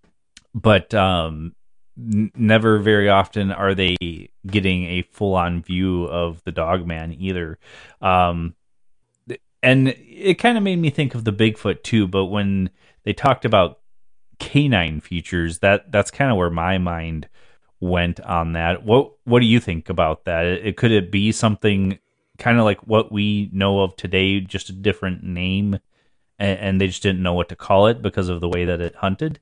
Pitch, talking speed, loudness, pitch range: 95 Hz, 185 wpm, -19 LUFS, 90-105 Hz